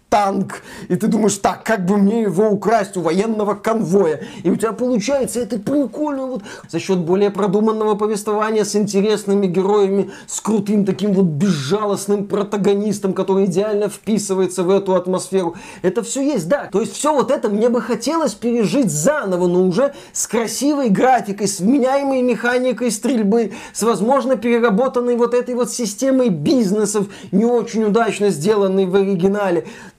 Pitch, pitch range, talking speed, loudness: 210 Hz, 195-240 Hz, 155 wpm, -17 LUFS